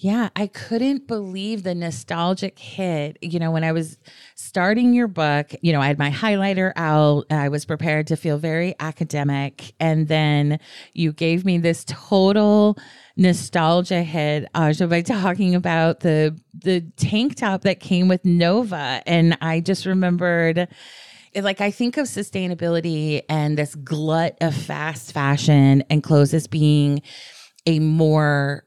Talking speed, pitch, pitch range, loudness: 155 wpm, 165 Hz, 150-185 Hz, -20 LUFS